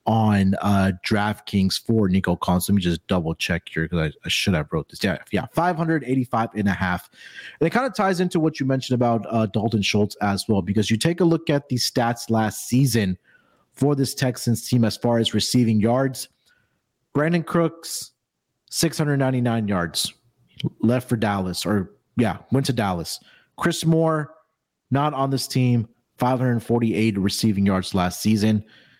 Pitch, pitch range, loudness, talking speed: 115 Hz, 100-135 Hz, -22 LUFS, 170 wpm